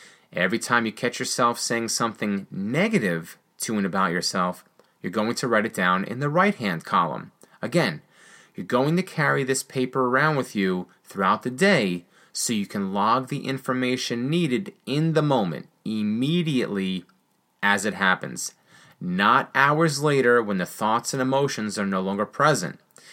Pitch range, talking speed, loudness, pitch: 105-150 Hz, 160 wpm, -24 LUFS, 130 Hz